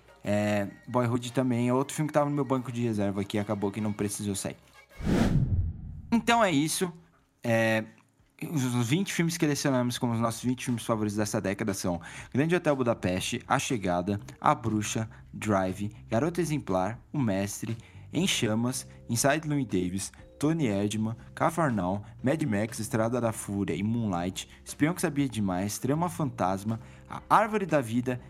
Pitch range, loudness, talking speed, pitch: 100-140 Hz, -29 LUFS, 155 wpm, 115 Hz